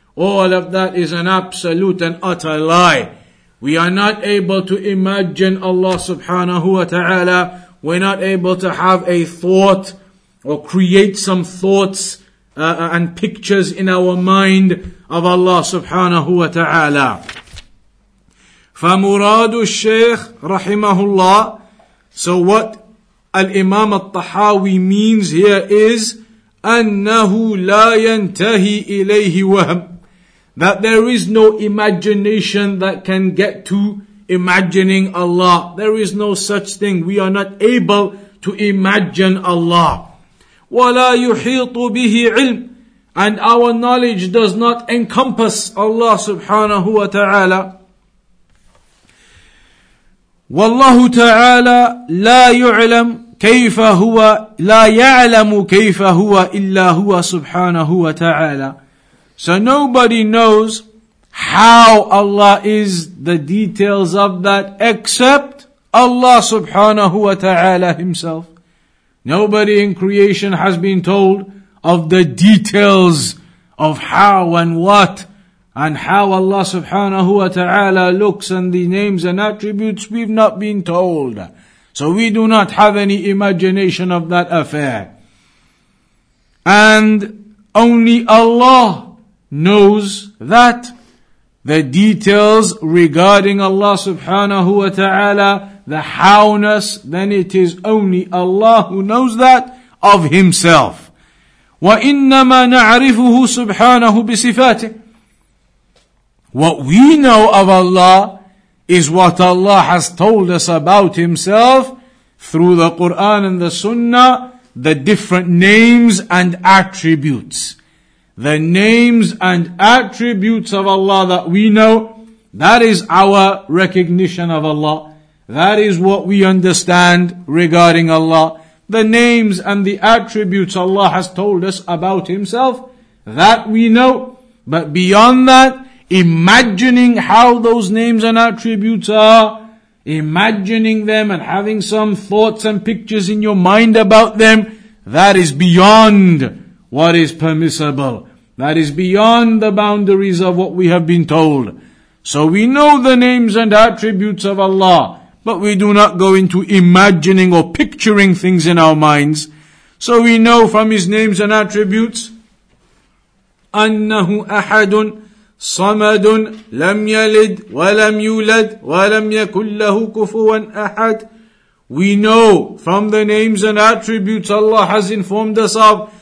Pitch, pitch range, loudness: 200 Hz, 180-220 Hz, -10 LUFS